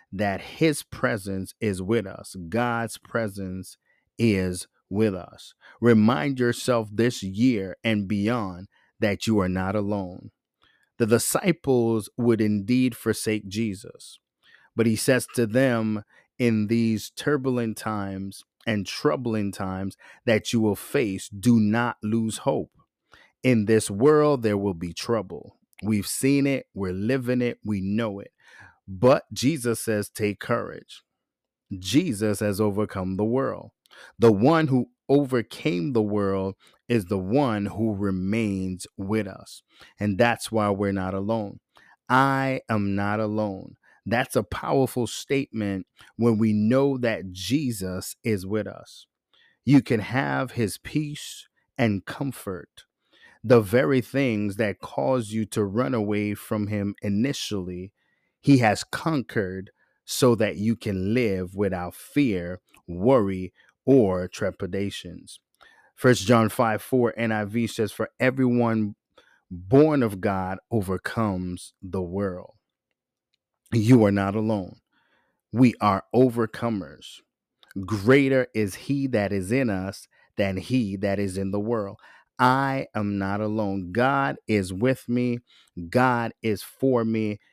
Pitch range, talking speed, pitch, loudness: 100-120 Hz, 130 wpm, 110 Hz, -24 LUFS